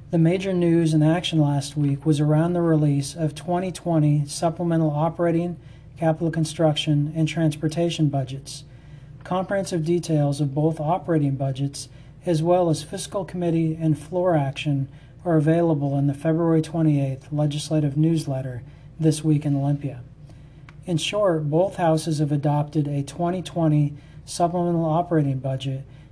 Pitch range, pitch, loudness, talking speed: 145-165 Hz, 155 Hz, -23 LUFS, 130 wpm